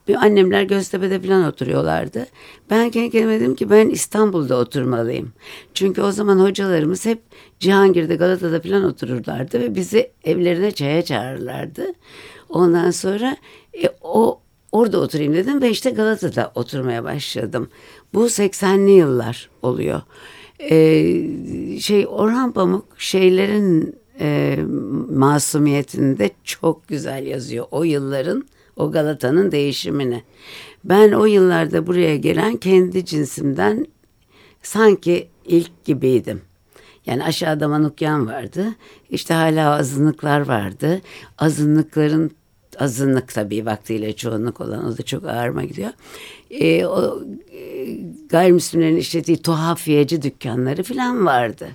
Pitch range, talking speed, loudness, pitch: 145-195 Hz, 110 wpm, -18 LUFS, 165 Hz